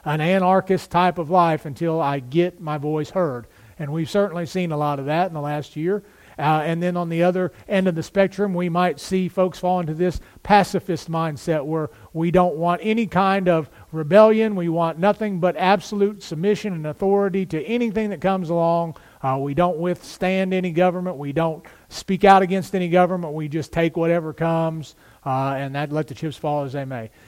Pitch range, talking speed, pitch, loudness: 155-190 Hz, 200 wpm, 175 Hz, -21 LUFS